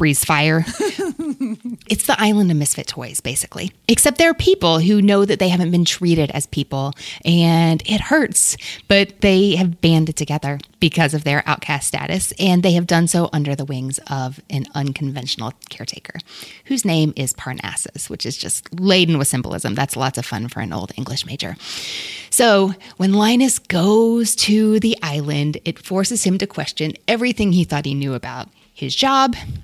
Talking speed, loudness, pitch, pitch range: 175 wpm, -17 LUFS, 165 Hz, 140-200 Hz